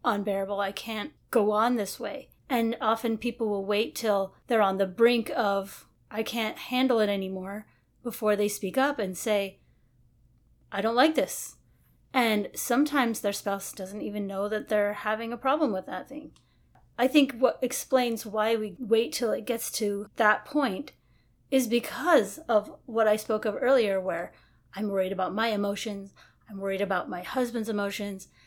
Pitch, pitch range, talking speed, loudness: 215 Hz, 200-235 Hz, 170 wpm, -28 LUFS